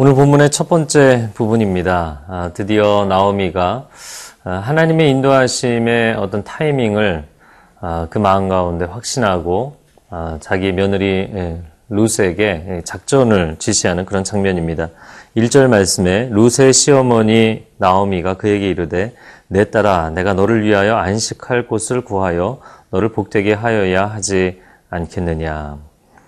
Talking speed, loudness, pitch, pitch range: 275 characters per minute, -15 LUFS, 100 Hz, 90-115 Hz